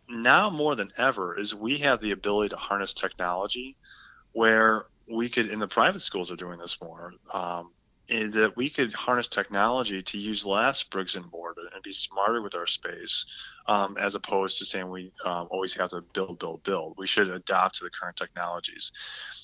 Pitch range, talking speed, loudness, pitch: 95-115 Hz, 190 wpm, -27 LUFS, 105 Hz